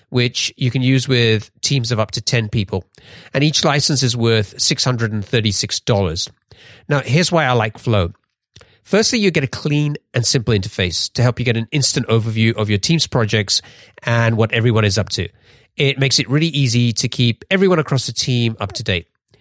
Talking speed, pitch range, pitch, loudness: 190 wpm, 110-140 Hz, 120 Hz, -17 LUFS